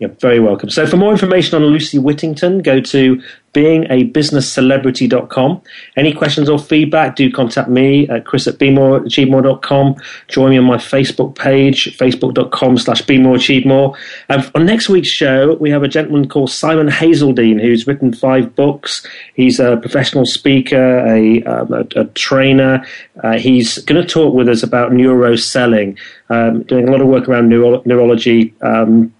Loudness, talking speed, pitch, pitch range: -11 LUFS, 165 wpm, 130 Hz, 125-145 Hz